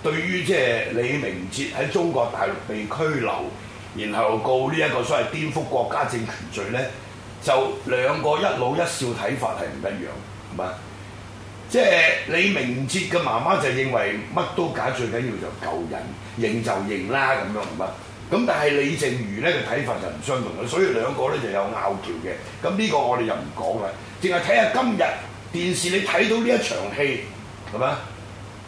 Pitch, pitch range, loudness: 115 Hz, 105-145 Hz, -23 LUFS